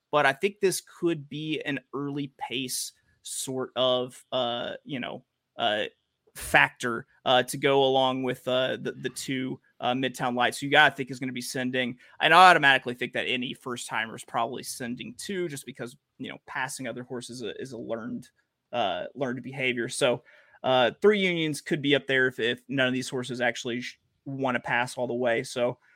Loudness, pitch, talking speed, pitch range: -27 LUFS, 130 Hz, 205 wpm, 125-140 Hz